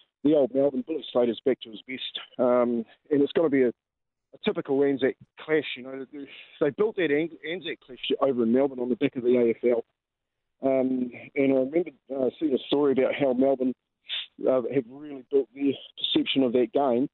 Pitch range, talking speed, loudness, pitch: 125-140 Hz, 205 wpm, -26 LUFS, 135 Hz